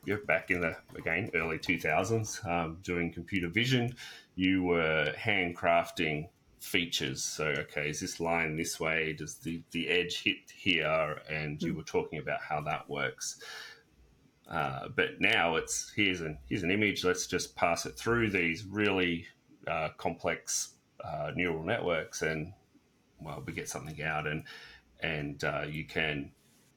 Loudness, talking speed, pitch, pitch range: -32 LUFS, 155 wpm, 85 Hz, 80-95 Hz